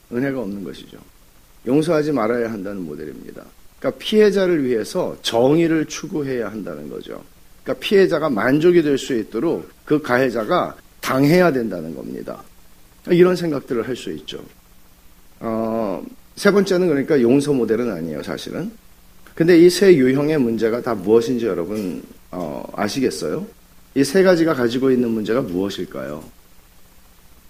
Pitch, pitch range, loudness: 130 Hz, 100-165 Hz, -19 LUFS